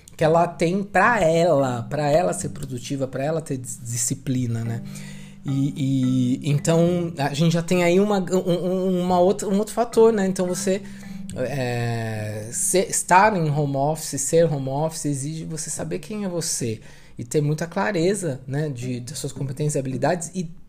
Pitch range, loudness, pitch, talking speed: 135-180 Hz, -22 LUFS, 160 Hz, 170 wpm